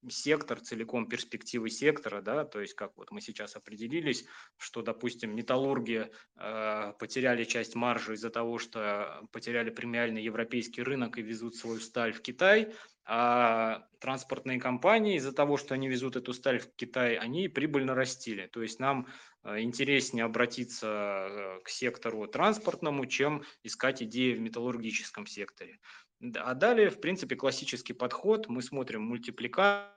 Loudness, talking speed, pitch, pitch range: -32 LUFS, 140 wpm, 120 Hz, 115-135 Hz